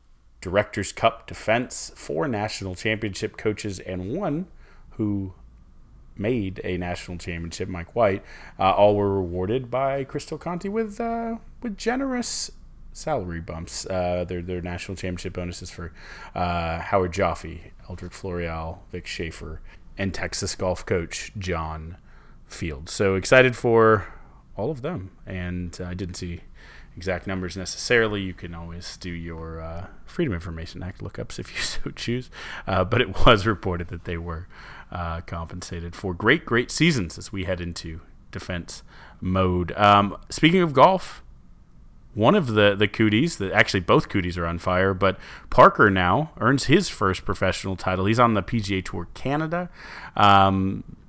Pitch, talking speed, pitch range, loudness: 95 Hz, 150 wpm, 85-110 Hz, -24 LUFS